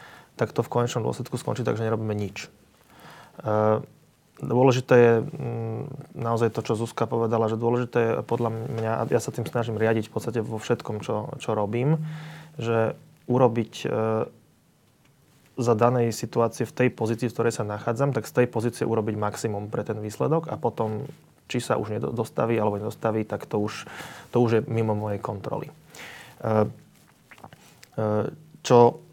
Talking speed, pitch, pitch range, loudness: 150 wpm, 115 Hz, 110-125 Hz, -26 LUFS